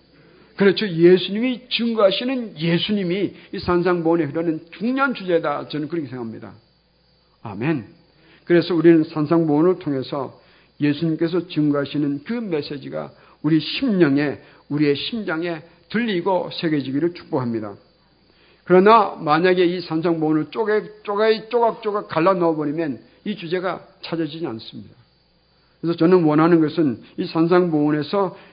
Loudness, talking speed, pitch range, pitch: -20 LUFS, 325 characters per minute, 155-190 Hz, 170 Hz